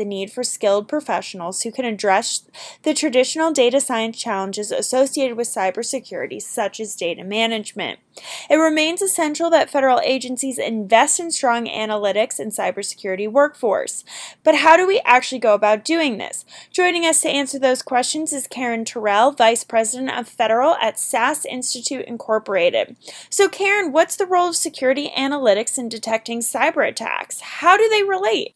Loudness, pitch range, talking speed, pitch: -18 LUFS, 225-315 Hz, 160 wpm, 255 Hz